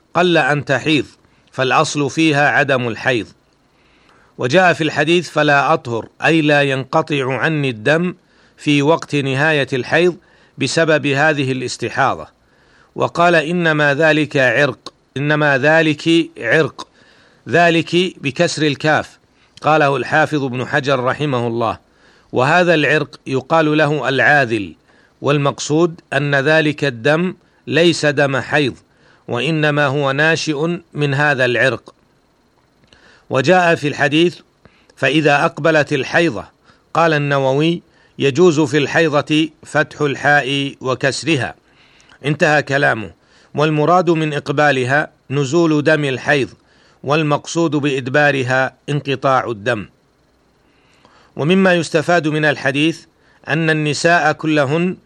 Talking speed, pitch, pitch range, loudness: 100 wpm, 150 Hz, 140-160 Hz, -15 LUFS